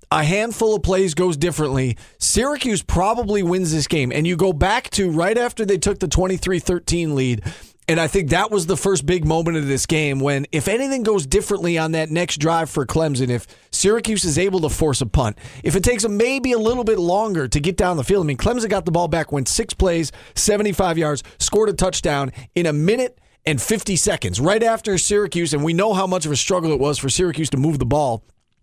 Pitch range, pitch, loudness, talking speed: 150-205 Hz, 175 Hz, -19 LUFS, 225 wpm